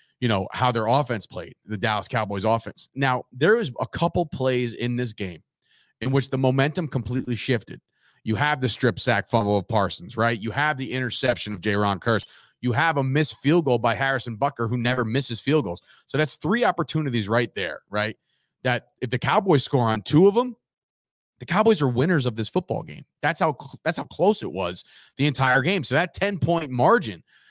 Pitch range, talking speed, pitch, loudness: 115-145 Hz, 205 wpm, 125 Hz, -23 LUFS